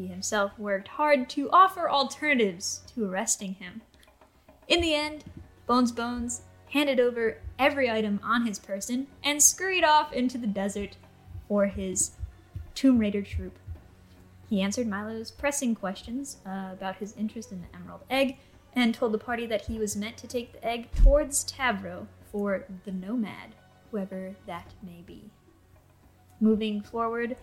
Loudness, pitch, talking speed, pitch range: -27 LUFS, 215 Hz, 150 wpm, 190-250 Hz